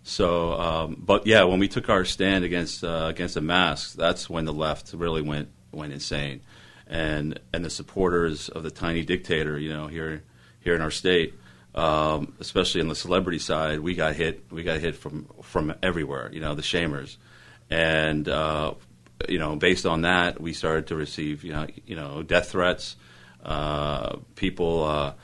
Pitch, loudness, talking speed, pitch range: 80 Hz, -26 LUFS, 180 wpm, 75-85 Hz